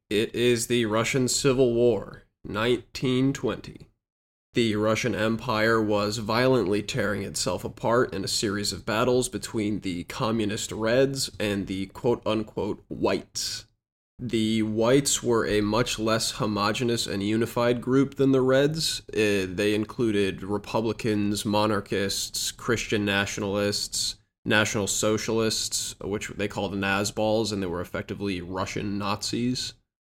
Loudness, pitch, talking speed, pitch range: -26 LUFS, 110 Hz, 120 wpm, 100-120 Hz